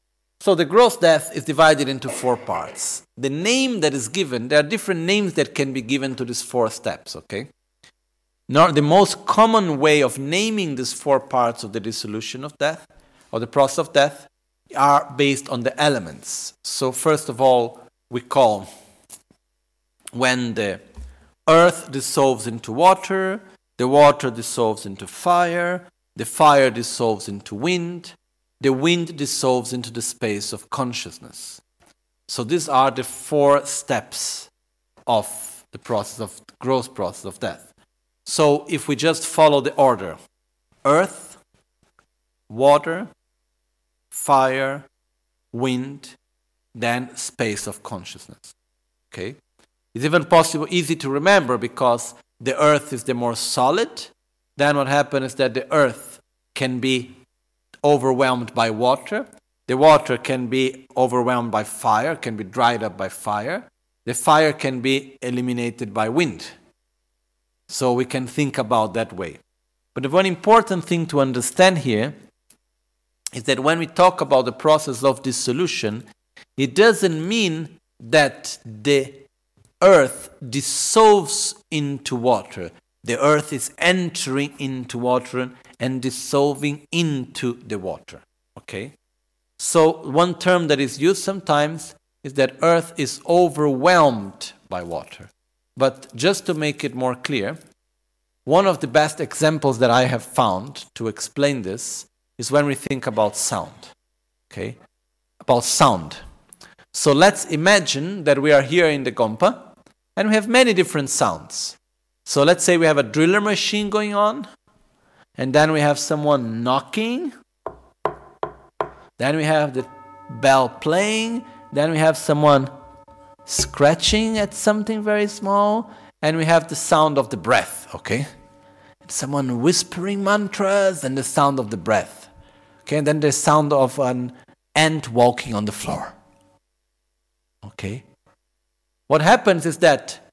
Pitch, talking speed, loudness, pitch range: 140 Hz, 140 wpm, -19 LUFS, 125-165 Hz